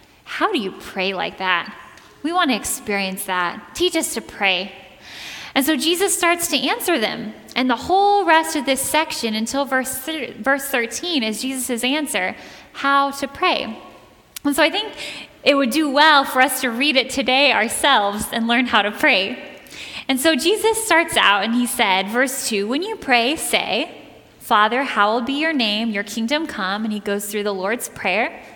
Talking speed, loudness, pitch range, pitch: 190 wpm, -19 LUFS, 220-305 Hz, 265 Hz